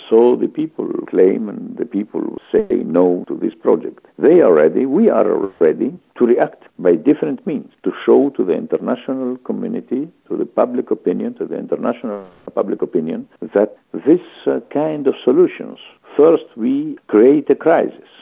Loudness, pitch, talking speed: -17 LUFS, 320 Hz, 160 wpm